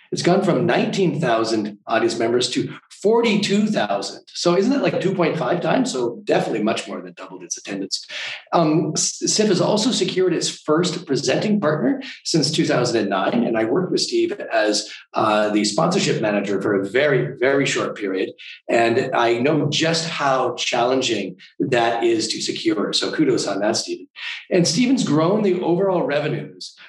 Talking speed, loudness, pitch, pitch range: 155 wpm, -20 LUFS, 180 Hz, 155-215 Hz